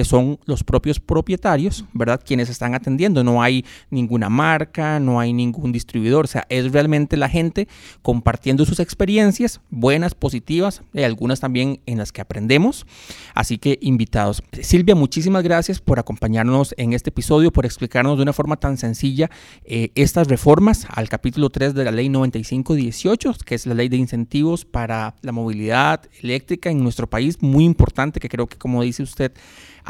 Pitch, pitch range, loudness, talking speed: 130 Hz, 120-155 Hz, -19 LUFS, 165 wpm